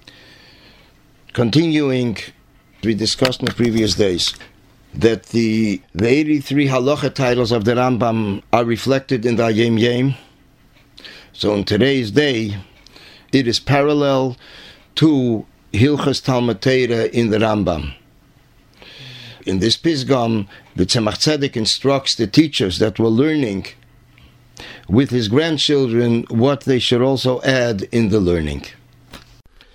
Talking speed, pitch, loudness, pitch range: 115 wpm, 125 Hz, -17 LUFS, 110-135 Hz